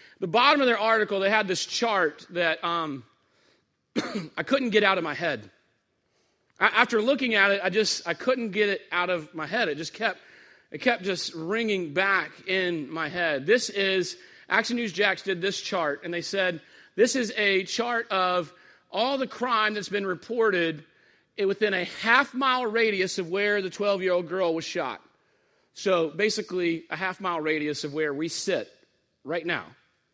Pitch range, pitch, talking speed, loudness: 175-225 Hz, 195 Hz, 185 wpm, -26 LUFS